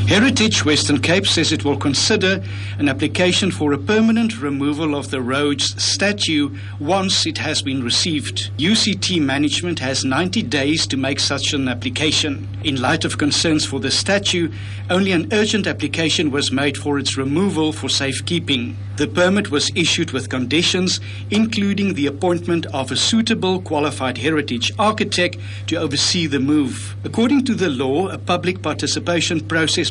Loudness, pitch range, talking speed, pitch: -18 LUFS, 105-155 Hz, 155 wpm, 140 Hz